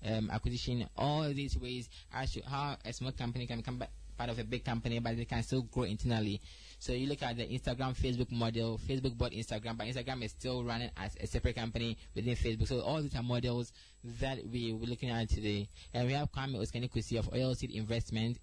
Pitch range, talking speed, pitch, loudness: 115-125 Hz, 215 wpm, 120 Hz, -37 LUFS